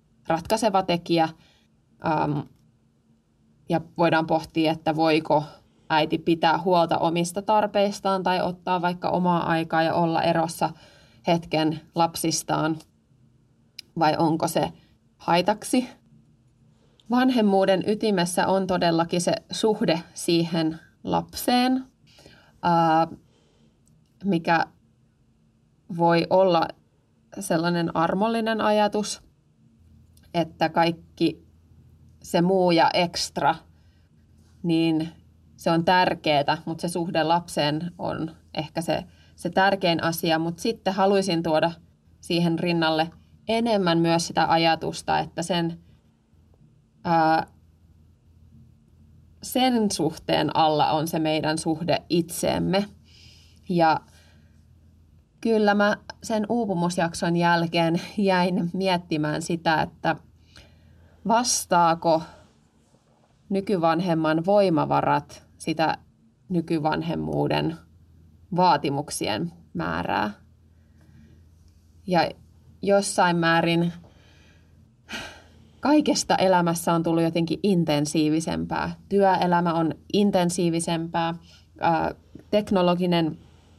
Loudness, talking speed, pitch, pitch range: -24 LUFS, 80 wpm, 165 Hz, 150-180 Hz